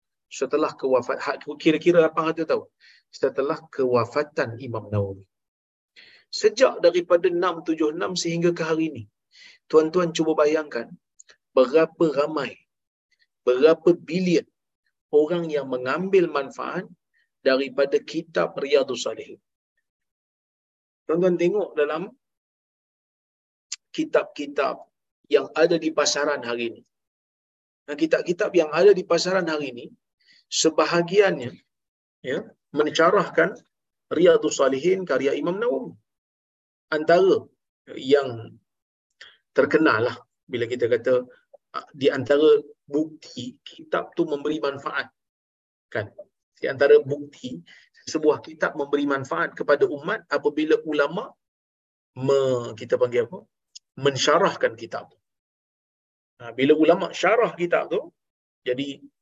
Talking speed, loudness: 95 wpm, -23 LUFS